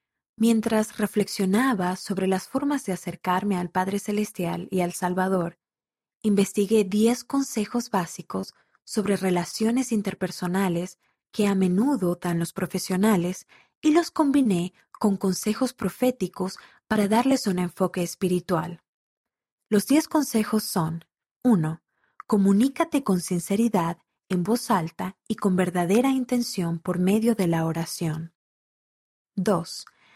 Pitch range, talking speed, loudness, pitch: 180-220 Hz, 115 wpm, -25 LUFS, 195 Hz